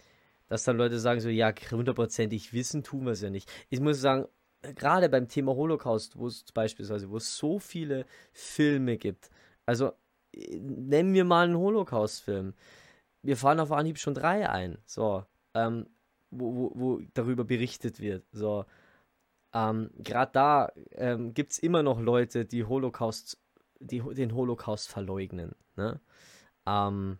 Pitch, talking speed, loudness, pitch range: 120 Hz, 145 wpm, -30 LUFS, 110-140 Hz